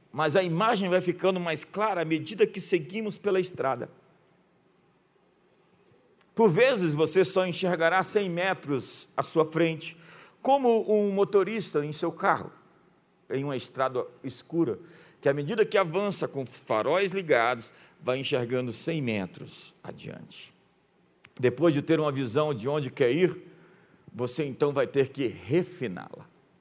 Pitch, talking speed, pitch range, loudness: 170 Hz, 140 wpm, 145-190 Hz, -27 LUFS